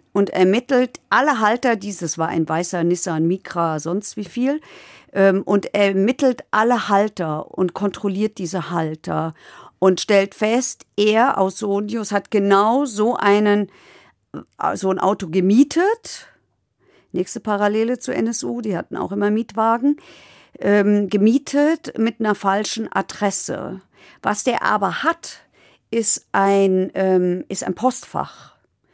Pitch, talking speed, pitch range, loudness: 205 Hz, 120 wpm, 190-230 Hz, -19 LUFS